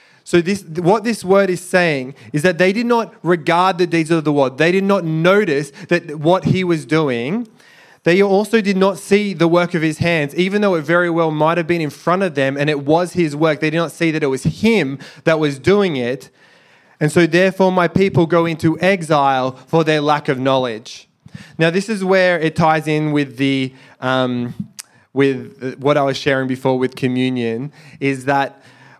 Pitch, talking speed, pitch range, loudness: 165 Hz, 205 wpm, 140-180 Hz, -16 LUFS